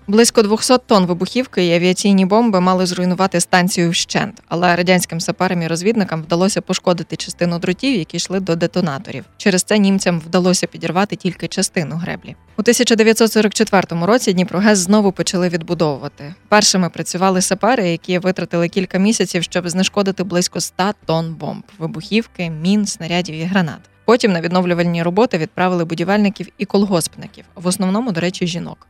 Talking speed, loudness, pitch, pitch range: 145 wpm, -16 LUFS, 185 Hz, 175-200 Hz